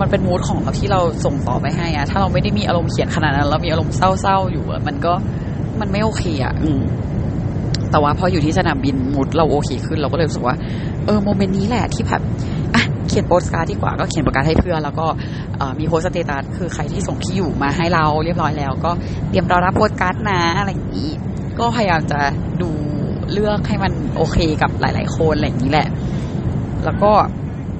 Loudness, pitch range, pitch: -18 LUFS, 135-155 Hz, 145 Hz